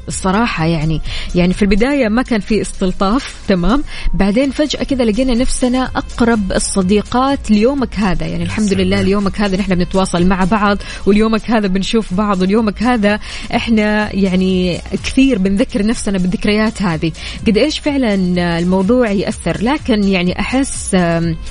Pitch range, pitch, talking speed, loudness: 190-235 Hz, 210 Hz, 135 wpm, -15 LUFS